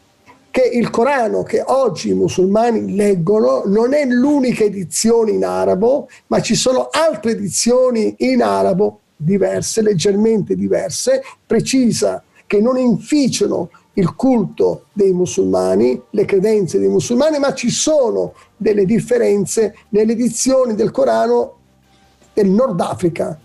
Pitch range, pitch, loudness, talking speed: 195-245 Hz, 215 Hz, -15 LUFS, 125 wpm